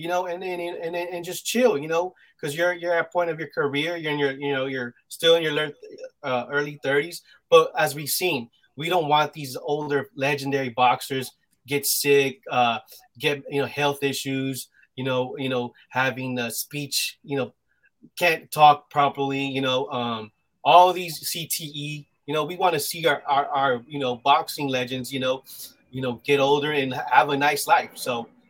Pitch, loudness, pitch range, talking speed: 145 Hz, -23 LUFS, 130-160 Hz, 185 wpm